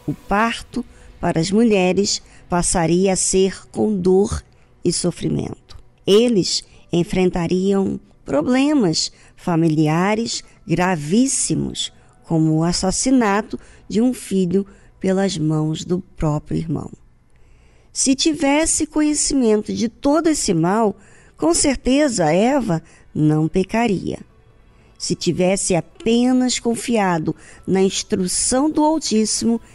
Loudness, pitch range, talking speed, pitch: -18 LUFS, 165-235 Hz, 95 wpm, 190 Hz